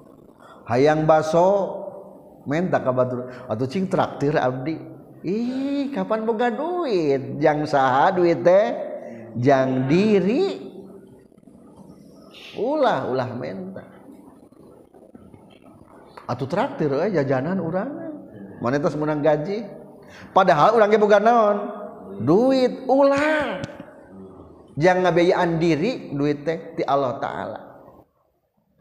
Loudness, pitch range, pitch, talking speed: -21 LUFS, 145-220 Hz, 175 Hz, 80 wpm